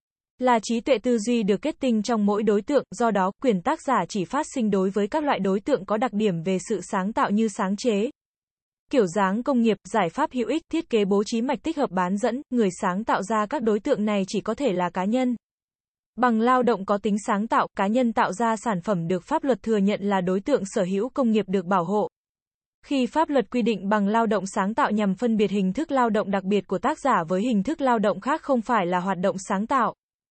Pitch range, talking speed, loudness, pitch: 200-255 Hz, 255 wpm, -24 LUFS, 220 Hz